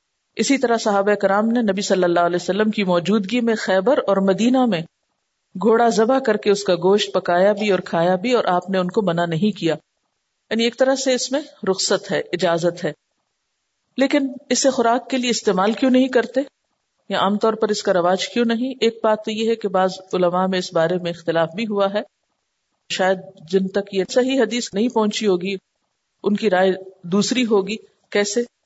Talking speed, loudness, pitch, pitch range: 200 wpm, -19 LUFS, 205 Hz, 185-235 Hz